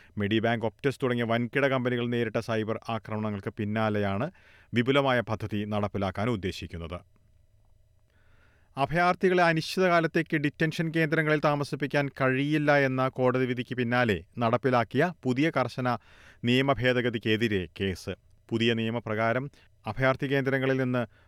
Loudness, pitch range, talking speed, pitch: -27 LUFS, 105-135 Hz, 95 wpm, 120 Hz